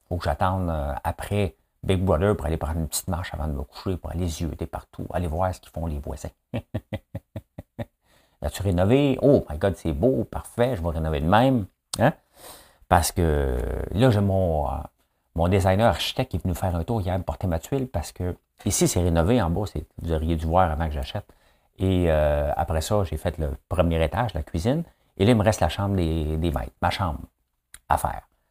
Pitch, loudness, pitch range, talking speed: 85 Hz, -25 LUFS, 80-95 Hz, 215 wpm